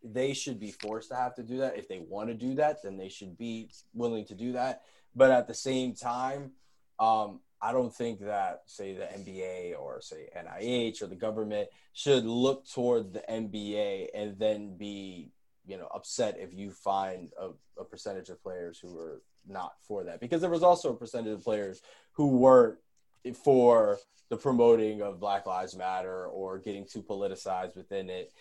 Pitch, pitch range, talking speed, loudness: 115 Hz, 100-130 Hz, 190 wpm, -30 LUFS